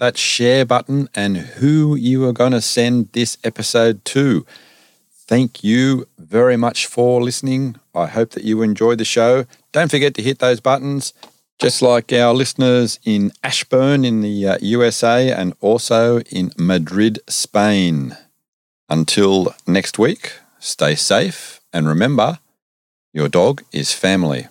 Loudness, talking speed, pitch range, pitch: -16 LUFS, 140 wpm, 105-130 Hz, 120 Hz